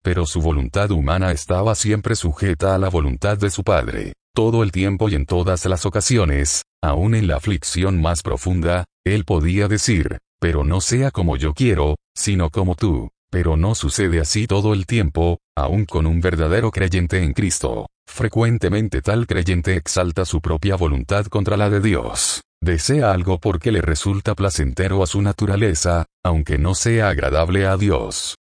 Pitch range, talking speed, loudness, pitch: 85-105 Hz, 165 wpm, -19 LUFS, 95 Hz